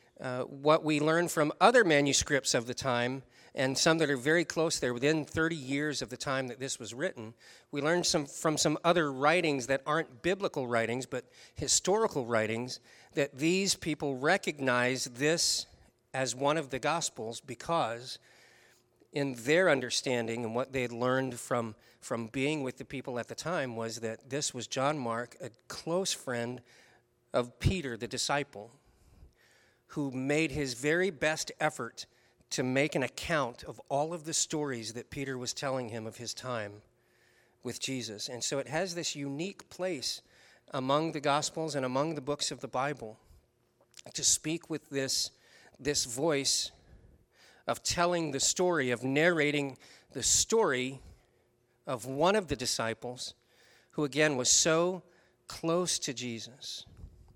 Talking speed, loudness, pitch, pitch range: 155 wpm, -31 LUFS, 135 Hz, 120-155 Hz